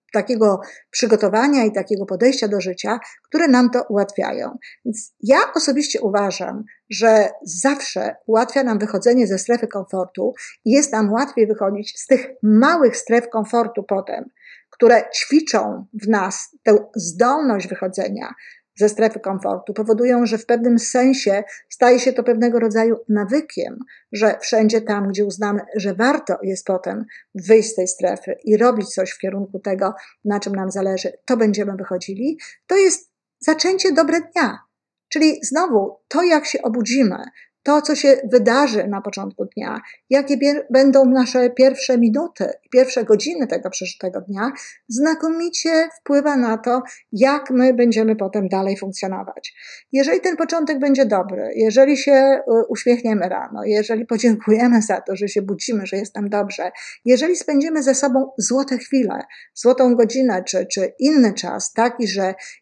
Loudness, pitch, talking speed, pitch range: -18 LUFS, 230 Hz, 145 wpm, 205-270 Hz